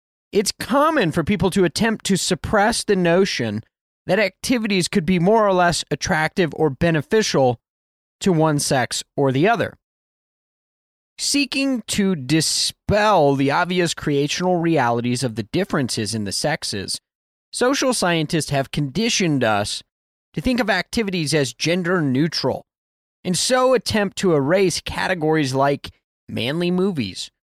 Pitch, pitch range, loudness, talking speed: 170 Hz, 135-200 Hz, -20 LUFS, 130 wpm